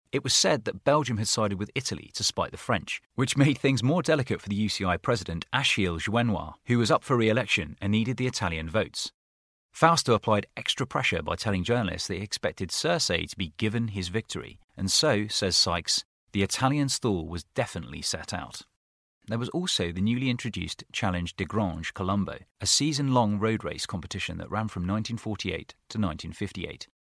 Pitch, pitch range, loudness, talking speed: 105 Hz, 90-120 Hz, -27 LUFS, 185 wpm